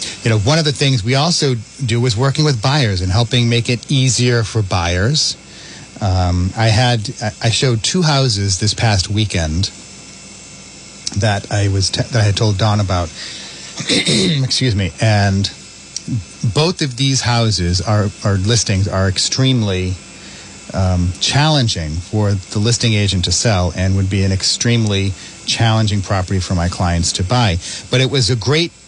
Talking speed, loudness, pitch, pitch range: 160 wpm, -15 LUFS, 105 Hz, 95-125 Hz